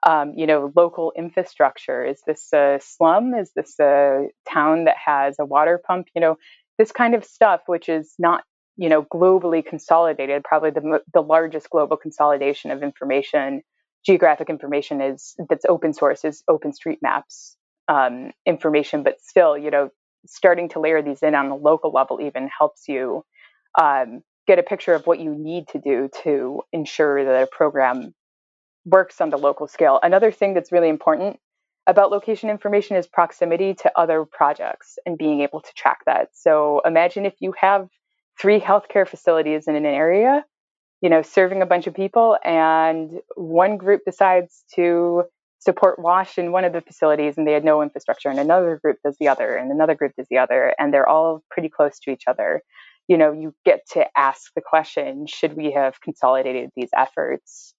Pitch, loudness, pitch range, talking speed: 160 Hz, -19 LUFS, 150-180 Hz, 180 wpm